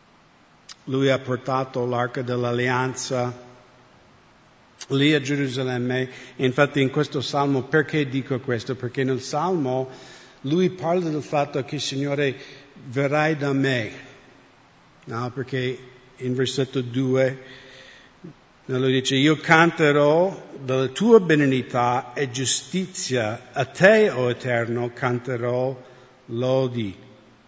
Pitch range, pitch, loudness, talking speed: 125-145 Hz, 130 Hz, -22 LUFS, 105 wpm